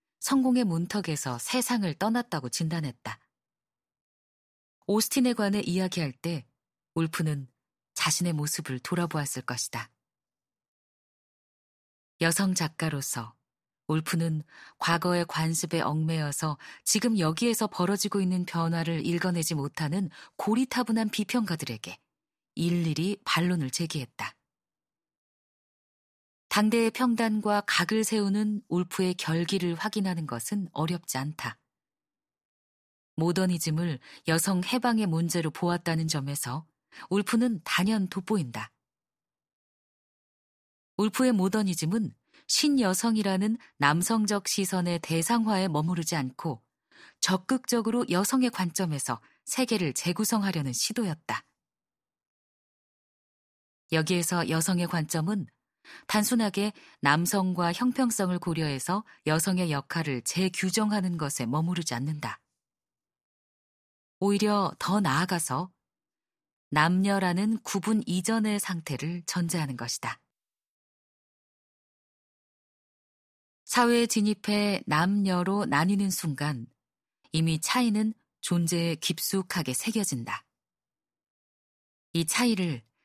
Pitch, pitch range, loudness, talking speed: 175 Hz, 155-205 Hz, -28 LUFS, 235 characters per minute